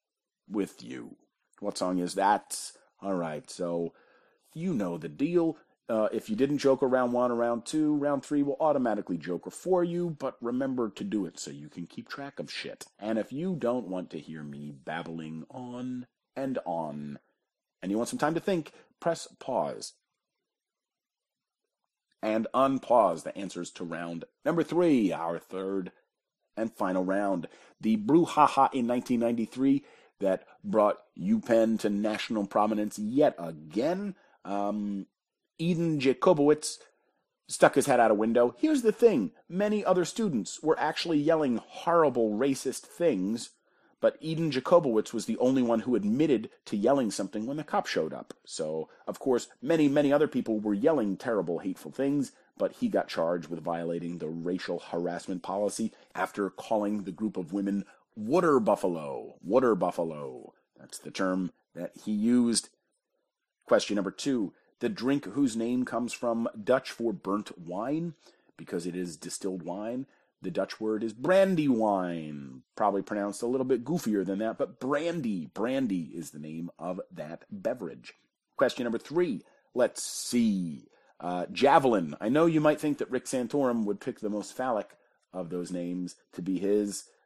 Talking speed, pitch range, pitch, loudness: 160 wpm, 95-150 Hz, 115 Hz, -29 LUFS